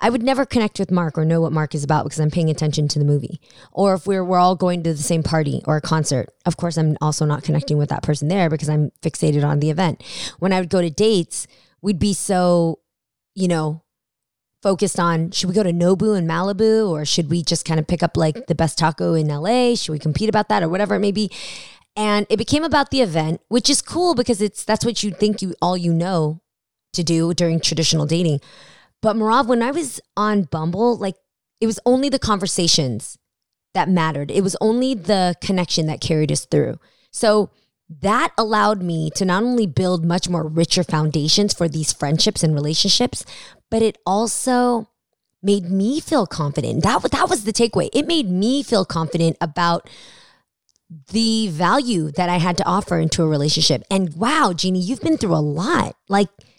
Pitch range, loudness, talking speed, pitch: 160-210 Hz, -19 LUFS, 205 wpm, 180 Hz